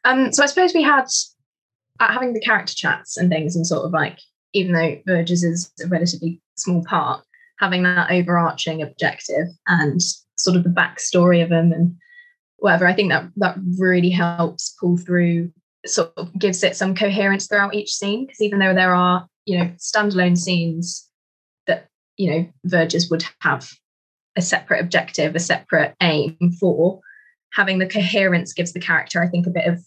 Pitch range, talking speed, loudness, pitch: 170-195 Hz, 175 wpm, -19 LUFS, 180 Hz